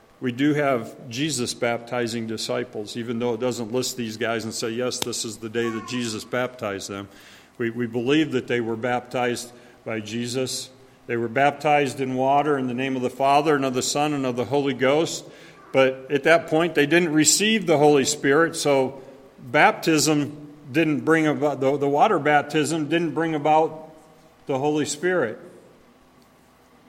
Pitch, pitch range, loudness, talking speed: 135 Hz, 120-150 Hz, -22 LUFS, 175 wpm